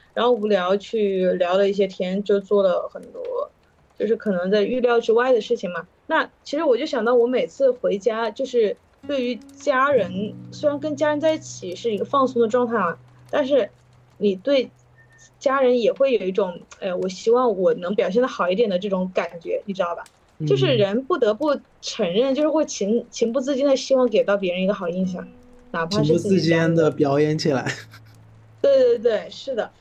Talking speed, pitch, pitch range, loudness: 280 characters per minute, 220 Hz, 180-270 Hz, -21 LUFS